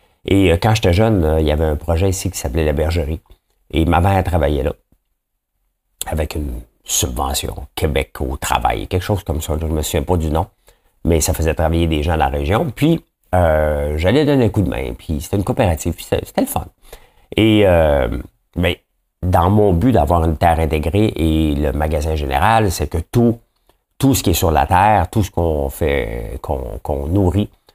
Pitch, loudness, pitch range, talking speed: 85 Hz, -17 LUFS, 80-100 Hz, 200 wpm